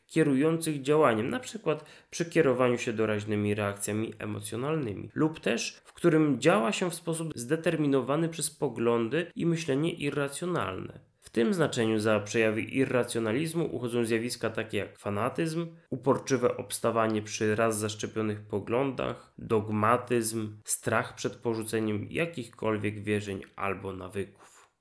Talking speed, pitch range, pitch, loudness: 115 wpm, 110-155 Hz, 120 Hz, -29 LUFS